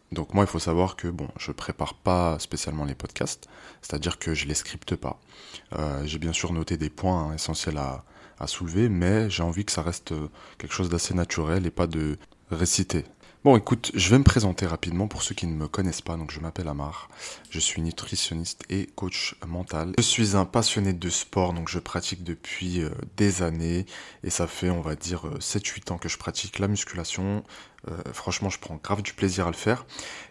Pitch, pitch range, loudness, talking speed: 85 Hz, 80-95 Hz, -27 LUFS, 205 wpm